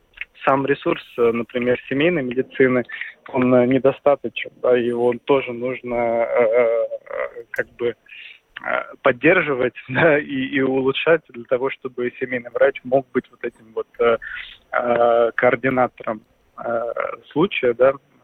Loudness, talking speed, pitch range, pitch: -20 LUFS, 110 wpm, 120-145 Hz, 130 Hz